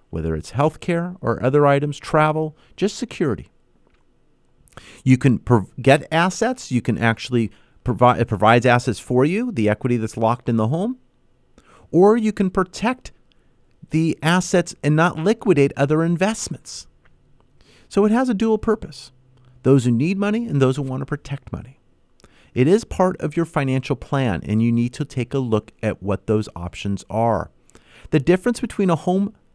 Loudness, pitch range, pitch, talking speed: -20 LUFS, 115-180 Hz, 140 Hz, 165 wpm